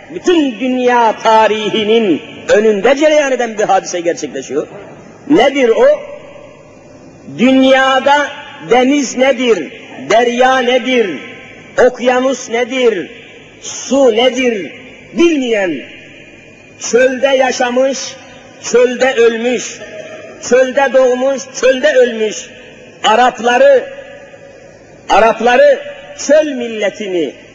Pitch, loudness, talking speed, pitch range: 255 Hz, -12 LUFS, 75 wpm, 235-275 Hz